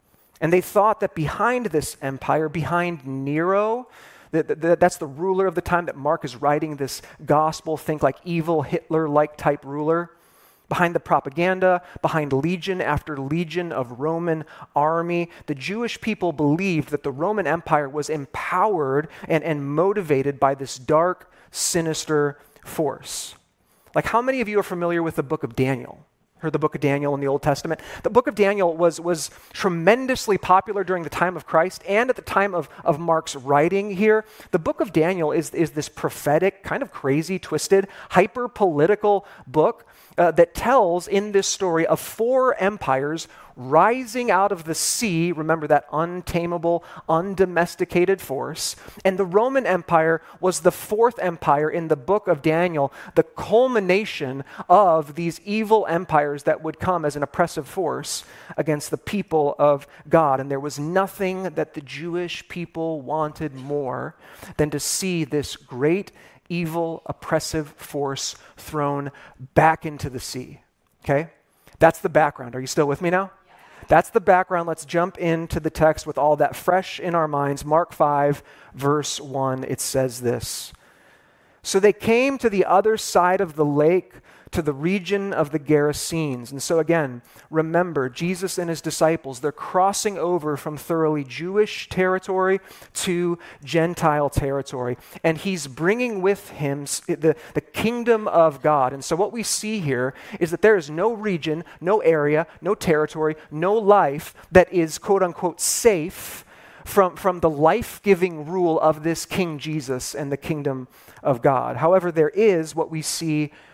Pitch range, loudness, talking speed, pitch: 150-185 Hz, -22 LUFS, 160 wpm, 165 Hz